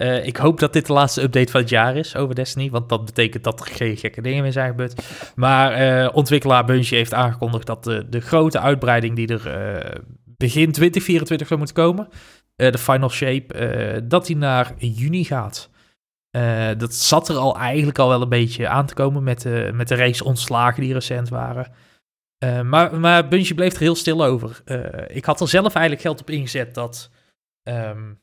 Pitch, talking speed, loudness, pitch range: 130 Hz, 200 wpm, -19 LUFS, 120-150 Hz